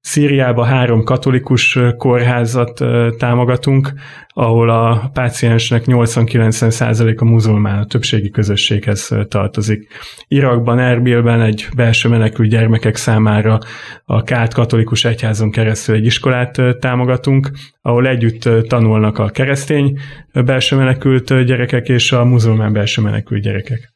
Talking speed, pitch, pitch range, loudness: 110 wpm, 120 Hz, 110-125 Hz, -13 LUFS